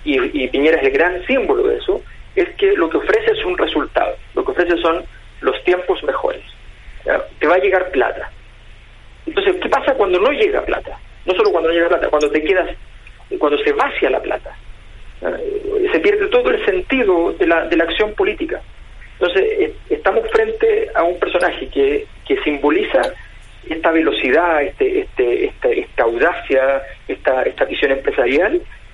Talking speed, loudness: 170 wpm, -17 LUFS